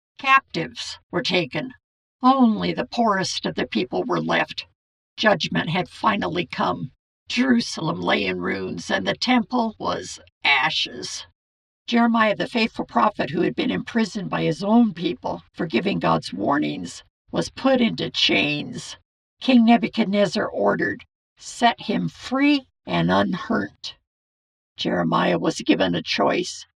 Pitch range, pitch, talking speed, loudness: 165-245 Hz, 225 Hz, 130 wpm, -22 LUFS